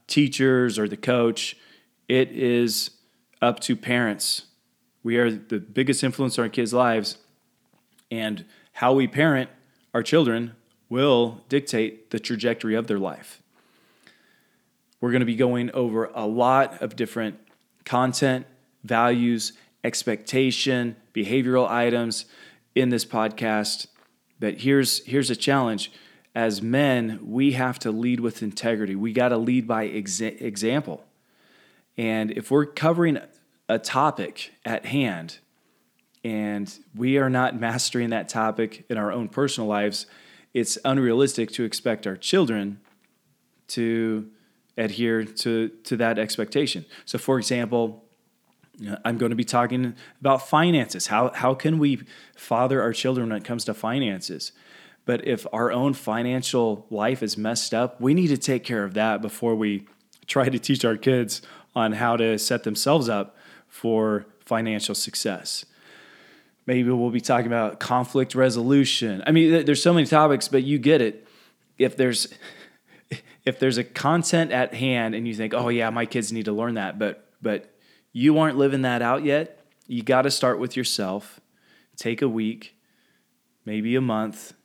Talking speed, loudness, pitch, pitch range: 150 wpm, -24 LUFS, 120 Hz, 110-130 Hz